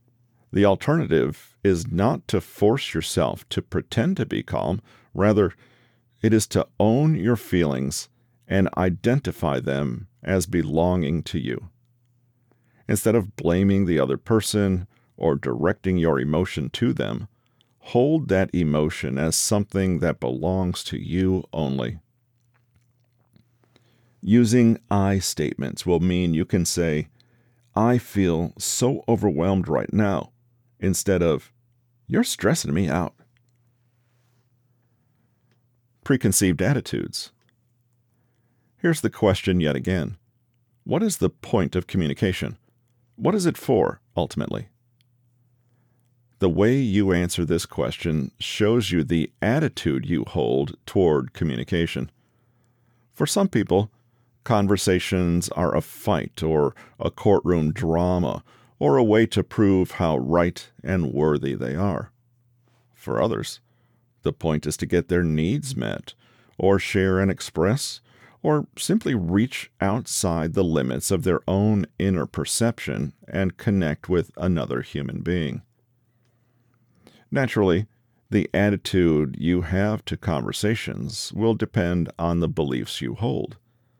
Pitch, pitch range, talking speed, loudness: 105 Hz, 90-120 Hz, 120 wpm, -23 LUFS